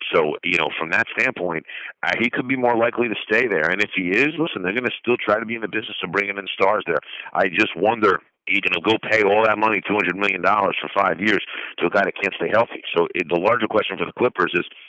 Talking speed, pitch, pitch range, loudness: 270 wpm, 105 Hz, 100-115 Hz, -20 LUFS